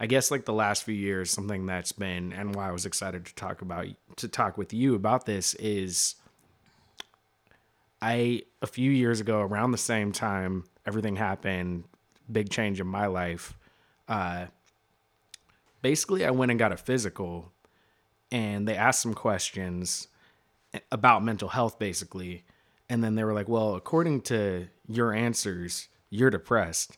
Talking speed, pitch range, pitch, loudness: 155 wpm, 95-115 Hz, 110 Hz, -28 LUFS